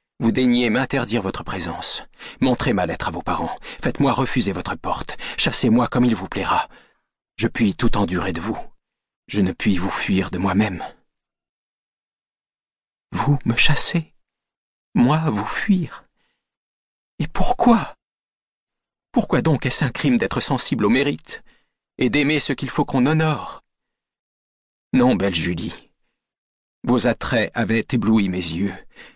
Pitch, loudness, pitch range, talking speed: 120 Hz, -20 LUFS, 100-150 Hz, 135 wpm